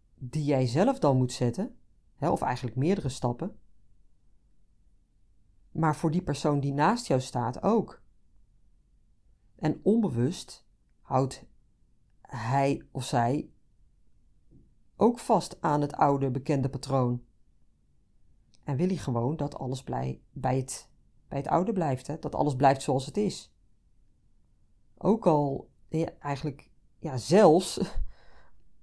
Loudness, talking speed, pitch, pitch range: -28 LUFS, 125 wpm, 135 Hz, 110-150 Hz